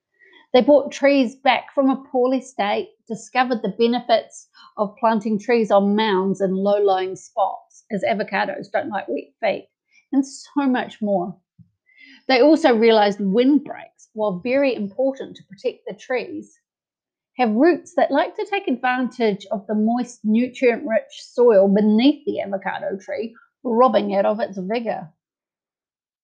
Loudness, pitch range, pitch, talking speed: -20 LUFS, 210-285 Hz, 250 Hz, 145 wpm